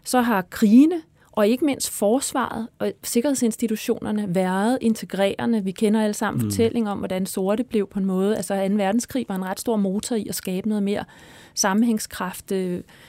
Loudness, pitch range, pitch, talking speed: -22 LUFS, 195-230 Hz, 210 Hz, 170 wpm